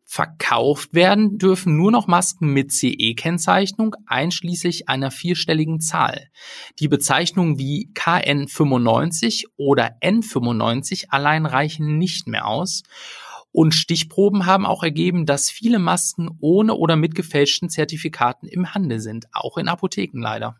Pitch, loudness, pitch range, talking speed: 165 Hz, -19 LUFS, 145-185 Hz, 125 wpm